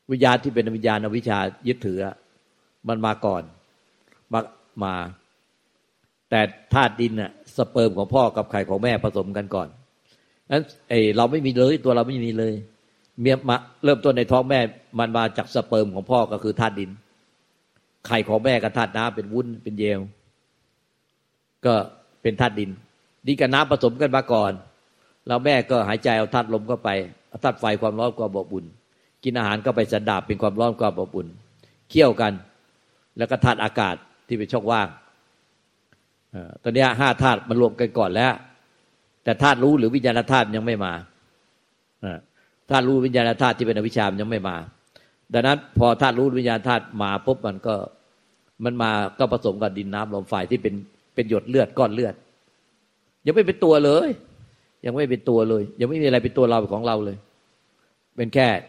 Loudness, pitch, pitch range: -22 LUFS, 115 Hz, 105-125 Hz